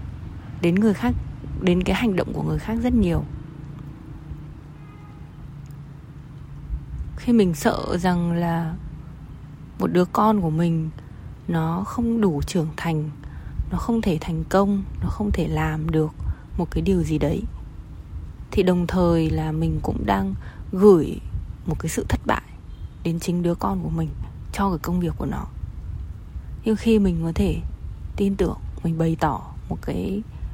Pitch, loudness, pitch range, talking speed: 165 Hz, -23 LUFS, 120-180 Hz, 155 wpm